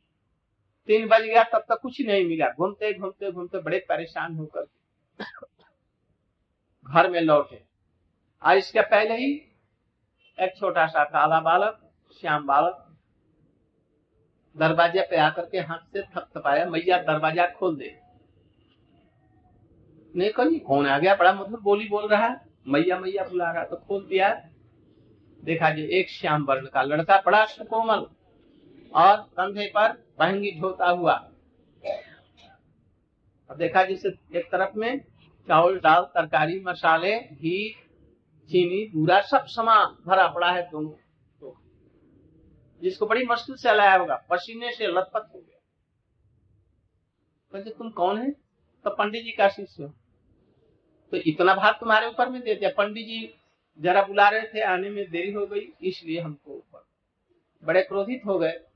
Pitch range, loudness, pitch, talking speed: 155-205 Hz, -23 LUFS, 185 Hz, 135 wpm